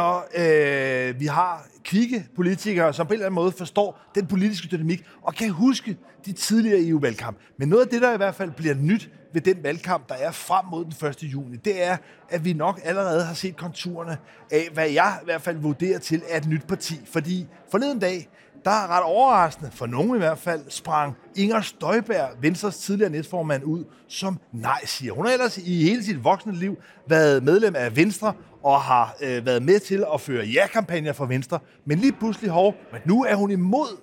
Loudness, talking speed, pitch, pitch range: -23 LUFS, 205 wpm, 175 Hz, 150-200 Hz